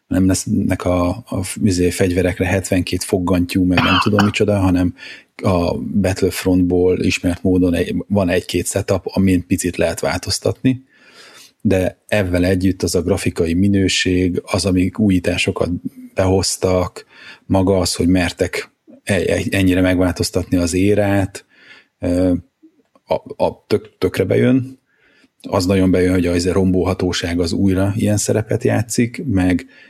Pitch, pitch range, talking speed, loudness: 95 Hz, 90-100 Hz, 130 wpm, -17 LUFS